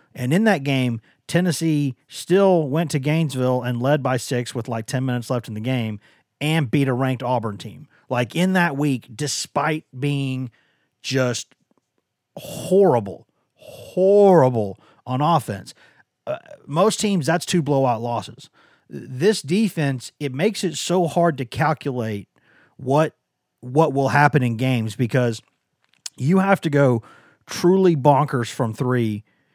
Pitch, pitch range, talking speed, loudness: 140 Hz, 125-165 Hz, 140 wpm, -21 LUFS